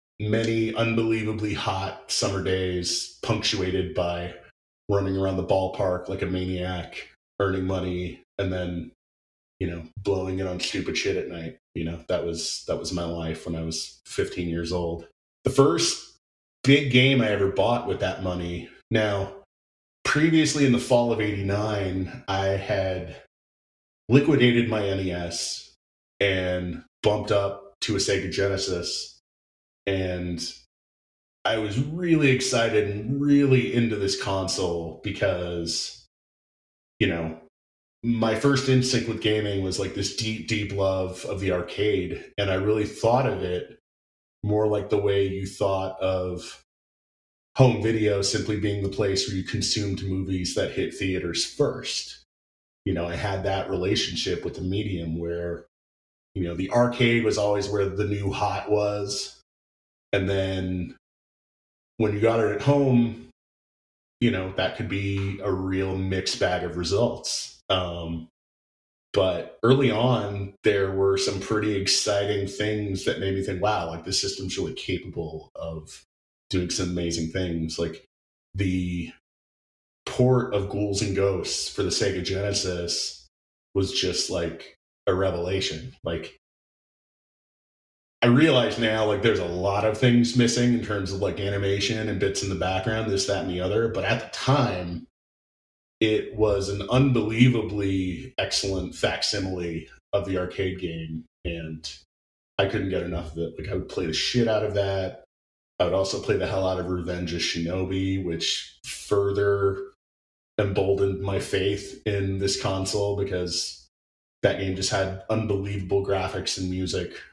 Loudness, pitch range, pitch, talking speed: -25 LUFS, 85-105 Hz, 95 Hz, 150 wpm